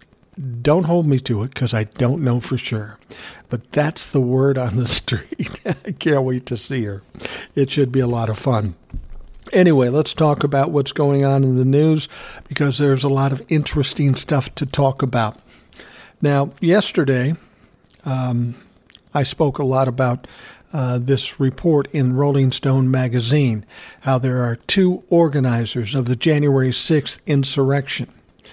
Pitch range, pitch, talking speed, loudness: 125-145 Hz, 135 Hz, 160 wpm, -19 LUFS